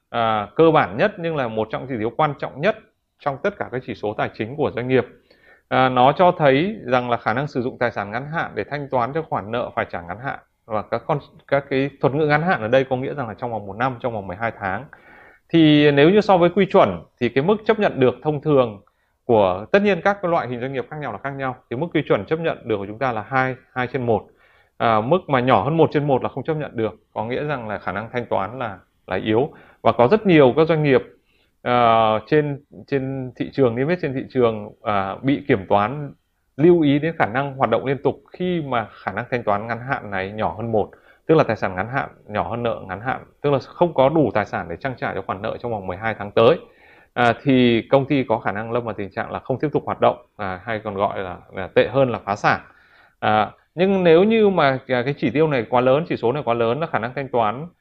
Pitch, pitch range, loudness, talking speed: 130 Hz, 115-150 Hz, -20 LUFS, 270 wpm